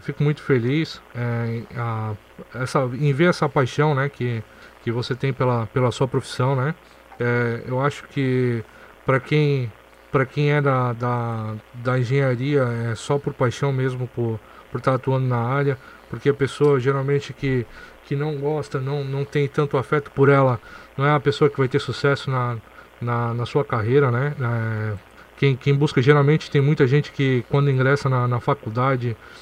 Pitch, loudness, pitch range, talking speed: 135 Hz, -22 LUFS, 120-145 Hz, 175 wpm